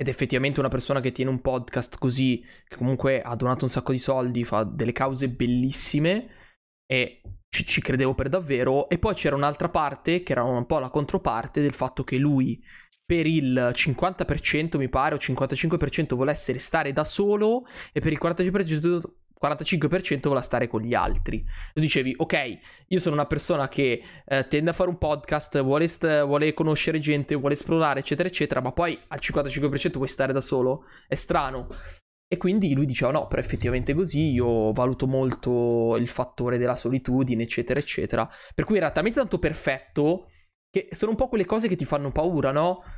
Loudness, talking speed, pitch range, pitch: -25 LUFS, 185 wpm, 130-160 Hz, 140 Hz